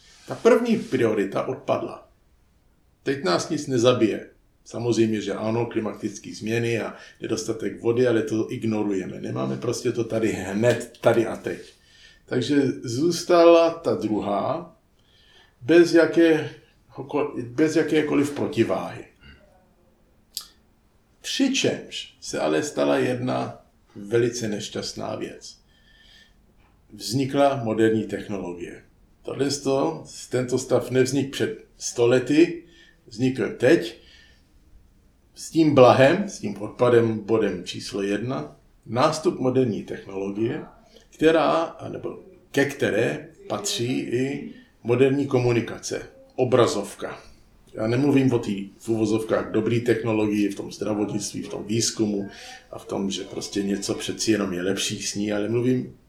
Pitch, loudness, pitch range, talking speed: 115 Hz, -23 LUFS, 105-135 Hz, 110 wpm